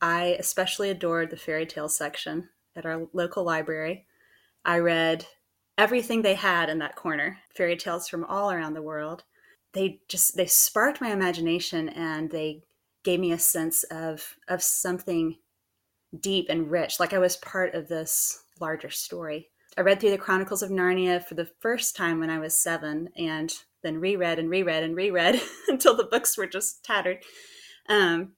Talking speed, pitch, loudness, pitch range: 170 wpm, 170 Hz, -26 LUFS, 160-190 Hz